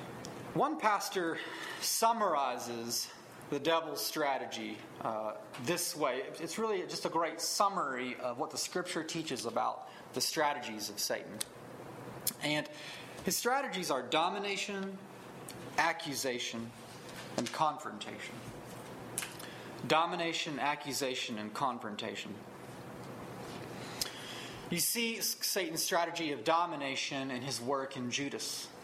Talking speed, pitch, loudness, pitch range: 100 wpm, 150 Hz, -35 LUFS, 125-170 Hz